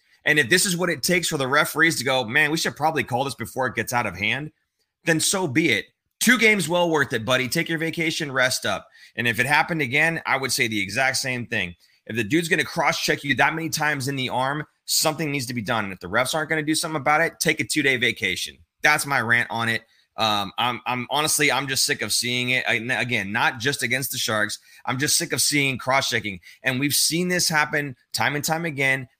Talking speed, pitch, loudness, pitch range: 255 wpm, 140 Hz, -21 LUFS, 120-160 Hz